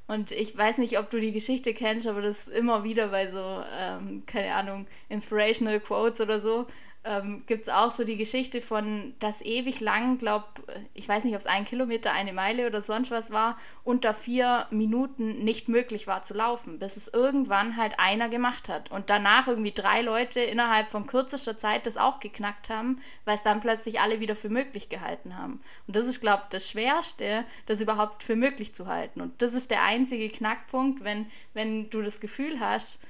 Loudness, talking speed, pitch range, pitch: -28 LUFS, 200 wpm, 210-240 Hz, 220 Hz